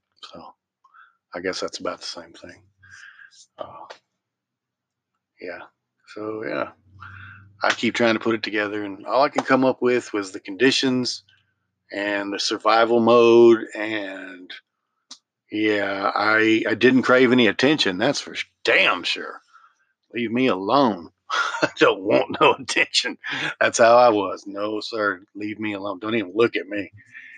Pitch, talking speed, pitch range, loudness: 110 Hz, 145 wpm, 100-120 Hz, -20 LUFS